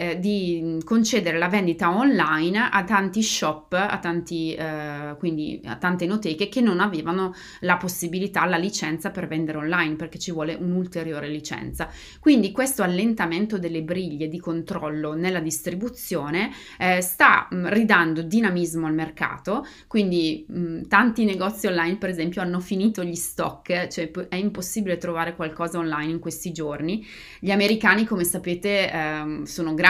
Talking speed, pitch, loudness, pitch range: 145 wpm, 175 Hz, -23 LUFS, 165-195 Hz